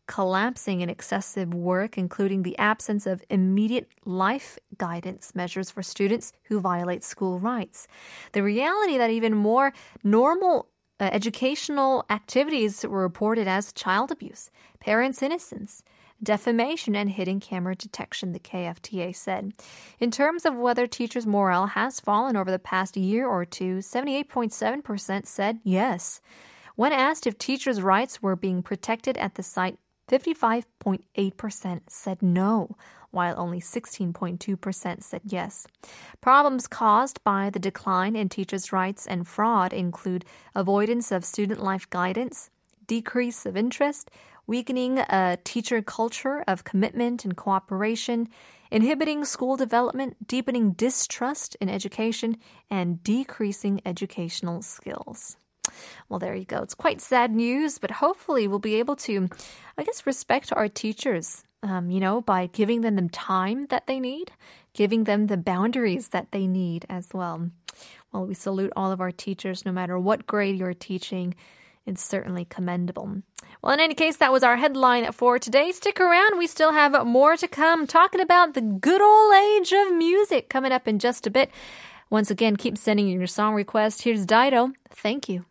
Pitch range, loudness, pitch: 190-250 Hz, -24 LUFS, 215 Hz